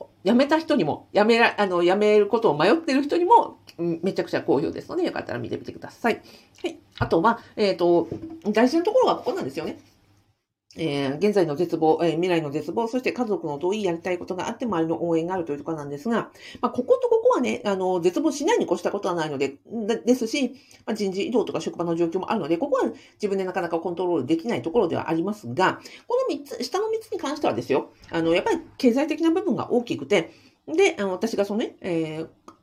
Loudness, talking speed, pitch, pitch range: -24 LUFS, 445 characters per minute, 200 Hz, 170-265 Hz